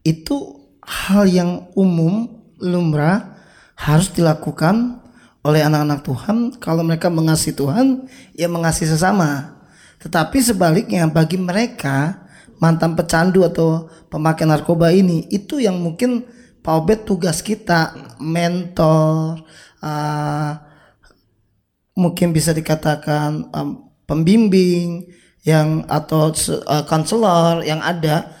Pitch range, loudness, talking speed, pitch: 155-185 Hz, -17 LUFS, 95 wpm, 165 Hz